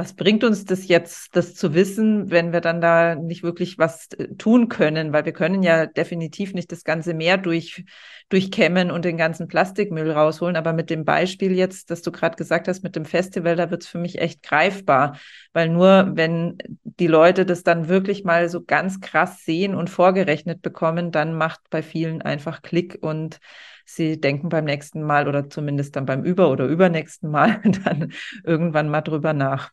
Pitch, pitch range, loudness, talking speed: 170 Hz, 160-185 Hz, -20 LUFS, 190 wpm